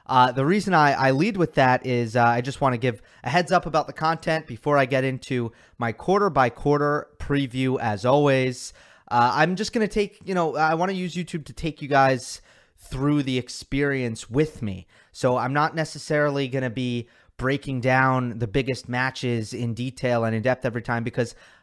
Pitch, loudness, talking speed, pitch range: 135 Hz, -23 LUFS, 205 wpm, 125-150 Hz